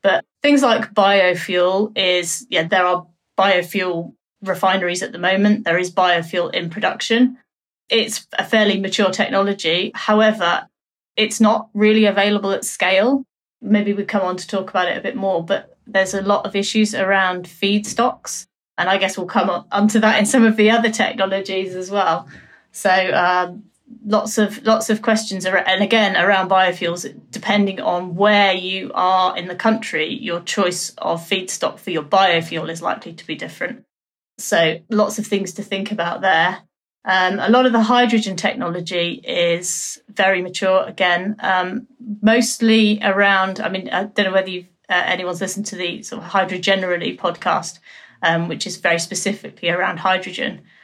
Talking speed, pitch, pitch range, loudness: 170 wpm, 195 Hz, 180-215 Hz, -18 LUFS